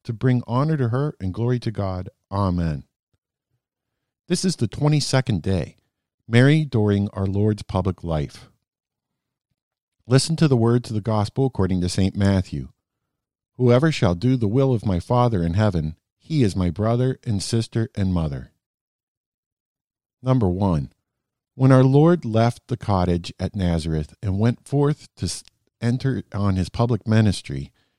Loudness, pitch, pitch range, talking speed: -21 LUFS, 110 Hz, 95-125 Hz, 150 wpm